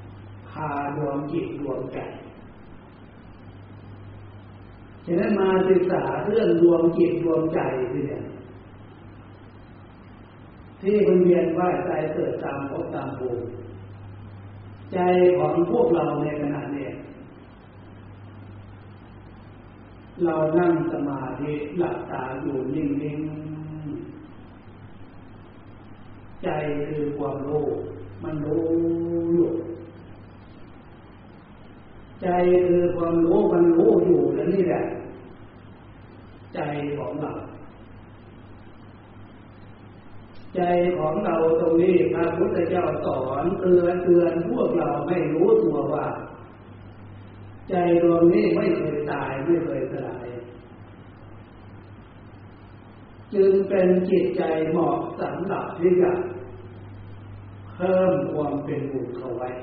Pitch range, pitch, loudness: 105-170 Hz, 120 Hz, -23 LUFS